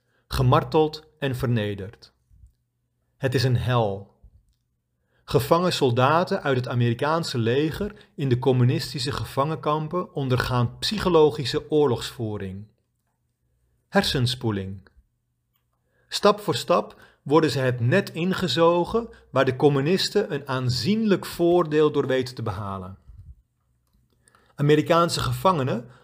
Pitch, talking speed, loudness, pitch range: 135 Hz, 95 wpm, -23 LUFS, 120-160 Hz